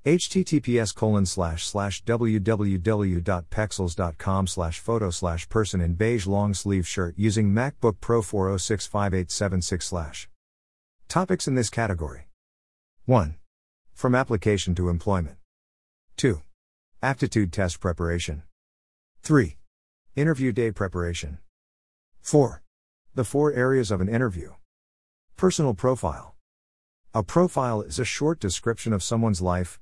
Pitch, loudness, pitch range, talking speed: 95 Hz, -25 LUFS, 85-115 Hz, 95 wpm